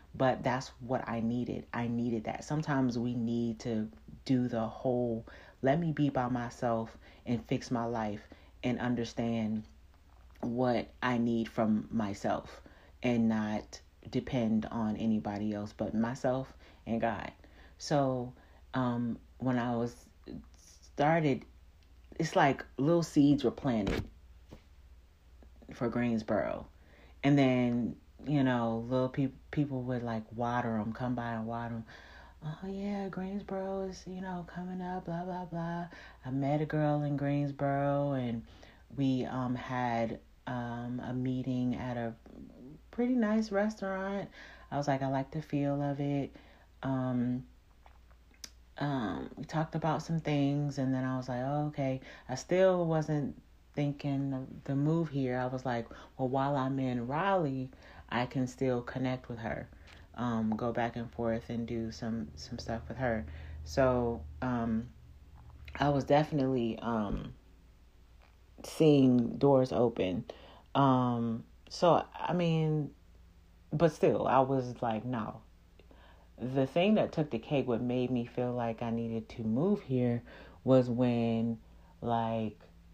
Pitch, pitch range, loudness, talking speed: 125 Hz, 110-140 Hz, -33 LUFS, 140 wpm